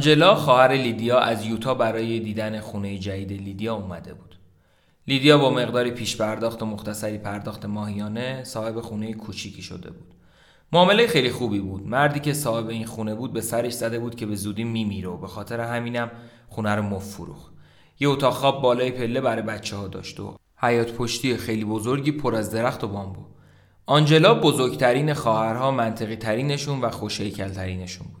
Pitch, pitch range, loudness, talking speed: 115 Hz, 105-125 Hz, -23 LUFS, 165 wpm